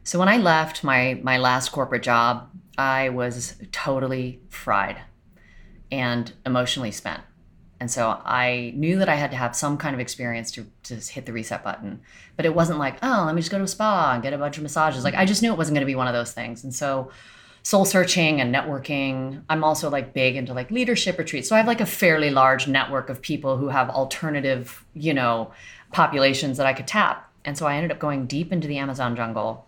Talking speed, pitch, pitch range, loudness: 225 wpm, 135 Hz, 125-155 Hz, -23 LUFS